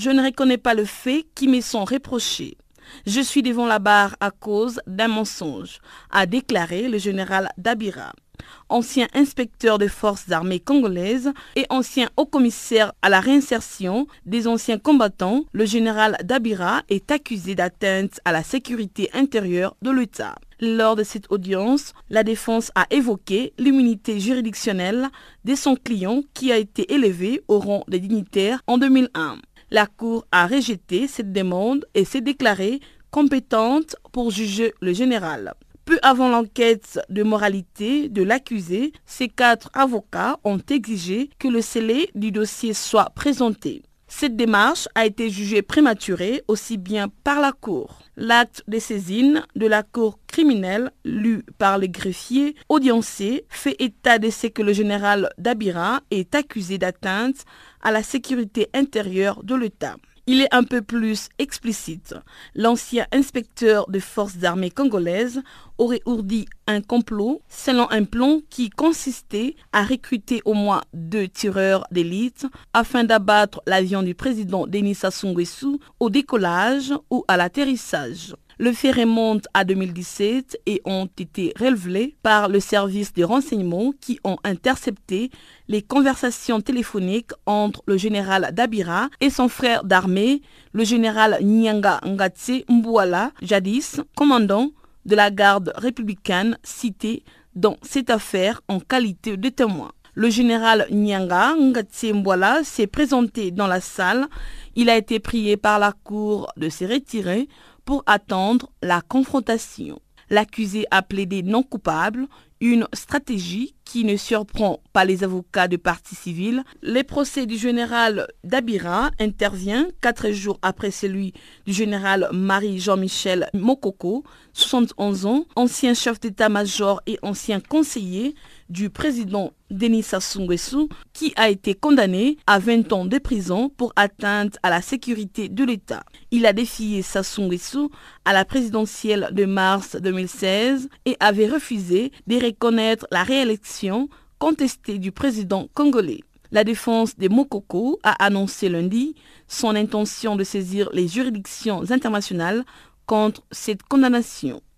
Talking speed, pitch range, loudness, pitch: 135 wpm, 200-255 Hz, -21 LUFS, 225 Hz